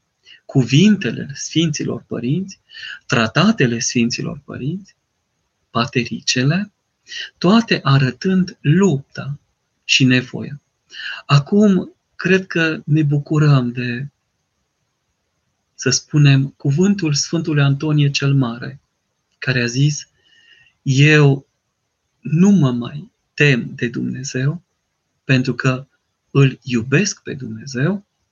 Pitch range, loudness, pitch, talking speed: 130-165 Hz, -17 LUFS, 140 Hz, 85 wpm